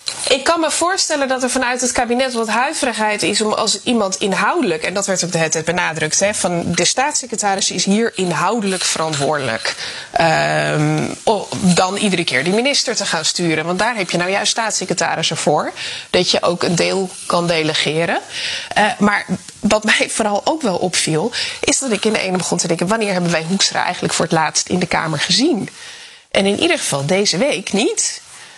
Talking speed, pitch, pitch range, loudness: 195 wpm, 200 Hz, 175-245 Hz, -16 LUFS